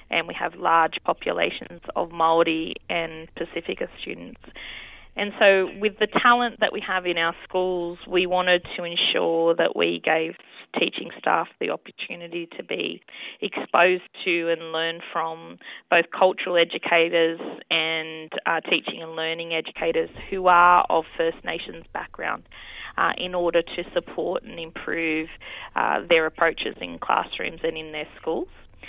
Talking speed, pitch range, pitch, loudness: 145 wpm, 165-180 Hz, 170 Hz, -23 LUFS